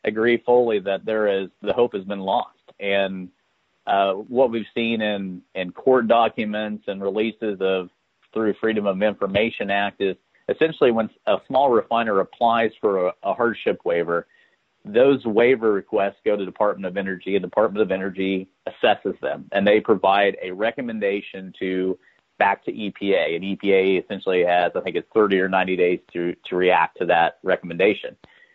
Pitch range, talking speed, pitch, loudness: 95-110 Hz, 170 wpm, 100 Hz, -22 LUFS